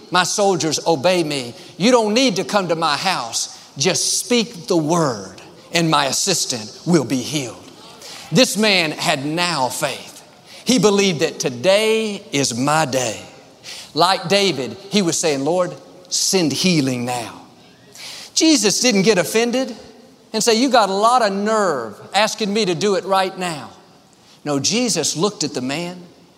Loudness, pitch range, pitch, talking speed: -18 LUFS, 155-210 Hz, 180 Hz, 155 wpm